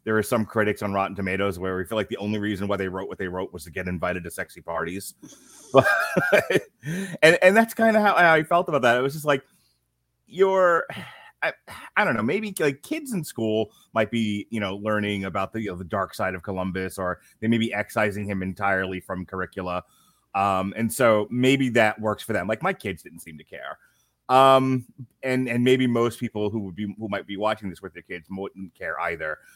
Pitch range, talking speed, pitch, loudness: 95-130 Hz, 225 wpm, 105 Hz, -24 LUFS